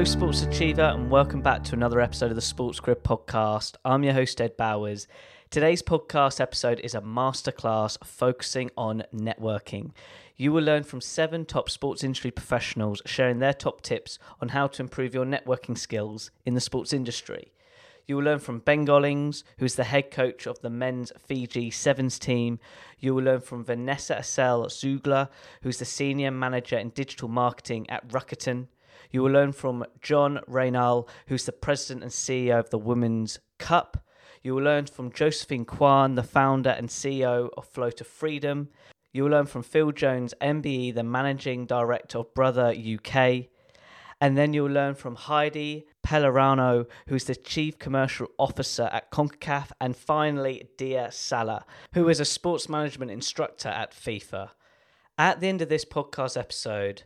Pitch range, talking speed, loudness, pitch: 120-140 Hz, 170 wpm, -26 LUFS, 130 Hz